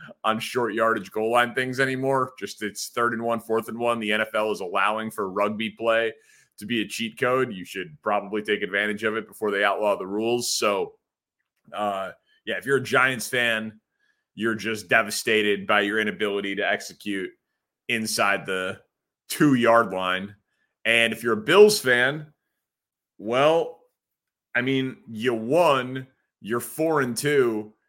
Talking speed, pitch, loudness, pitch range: 160 wpm, 115 Hz, -24 LUFS, 105-130 Hz